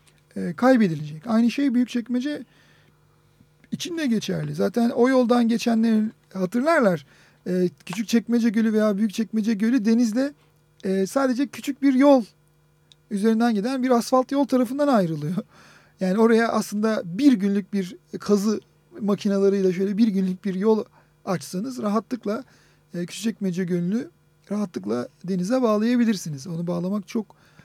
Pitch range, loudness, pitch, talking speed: 185-240 Hz, -23 LUFS, 215 Hz, 130 wpm